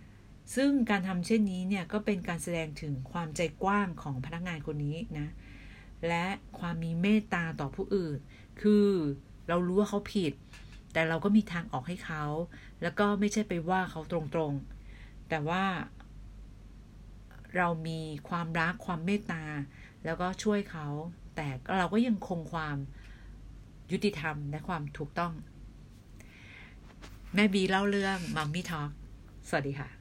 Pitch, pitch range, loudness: 165 Hz, 145-190 Hz, -32 LUFS